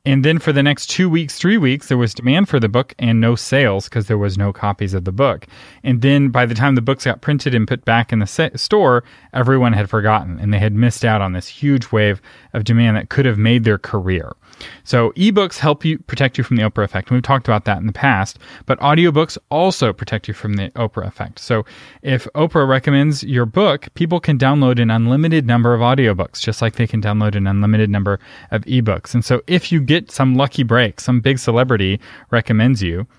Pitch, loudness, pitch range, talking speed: 120 Hz, -16 LUFS, 110-140 Hz, 225 wpm